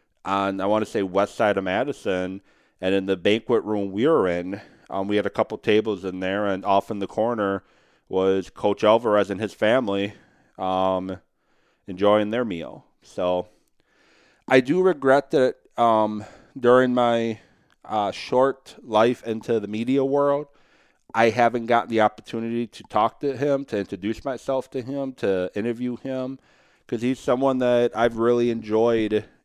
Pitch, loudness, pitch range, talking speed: 110 Hz, -23 LUFS, 100-125 Hz, 160 wpm